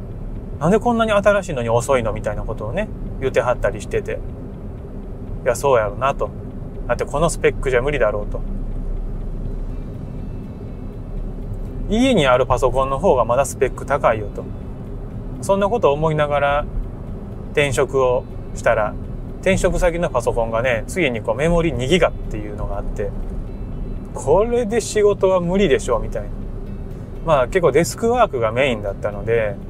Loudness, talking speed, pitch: -19 LUFS, 325 characters per minute, 125 Hz